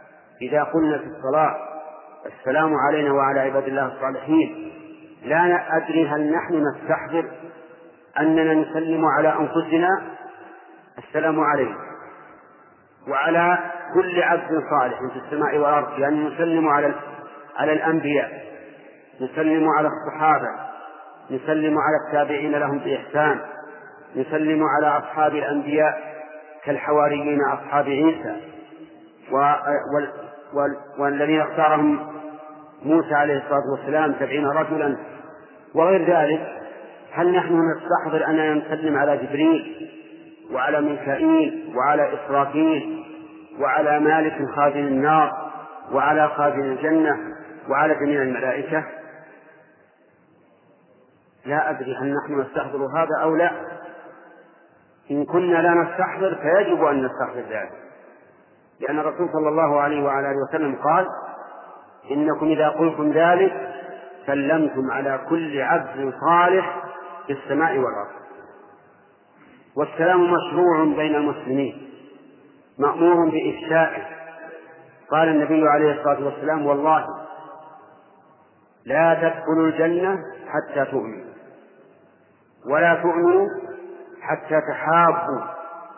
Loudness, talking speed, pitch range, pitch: -21 LUFS, 95 wpm, 145-170 Hz, 155 Hz